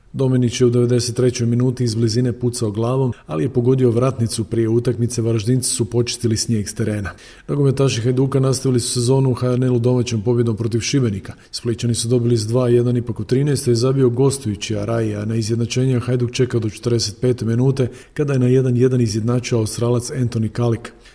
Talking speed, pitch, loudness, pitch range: 175 wpm, 120 Hz, -18 LUFS, 115-125 Hz